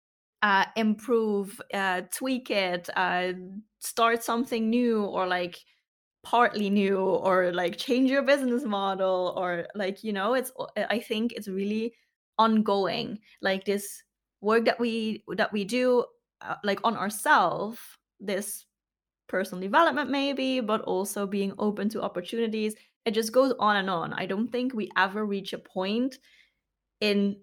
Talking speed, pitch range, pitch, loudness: 145 wpm, 195-235 Hz, 210 Hz, -27 LUFS